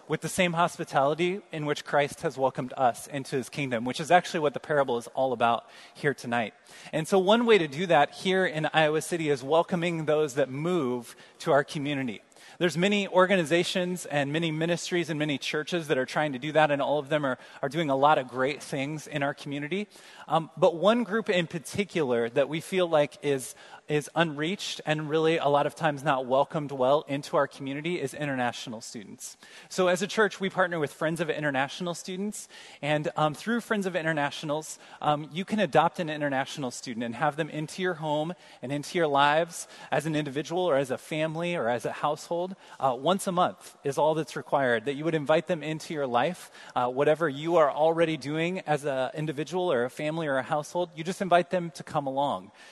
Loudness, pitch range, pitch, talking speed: -28 LUFS, 145-175 Hz, 155 Hz, 210 wpm